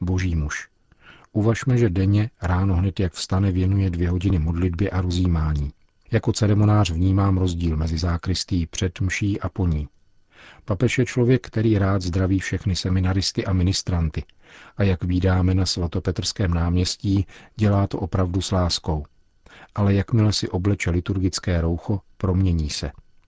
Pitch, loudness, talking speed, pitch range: 95 Hz, -22 LUFS, 140 wpm, 90-100 Hz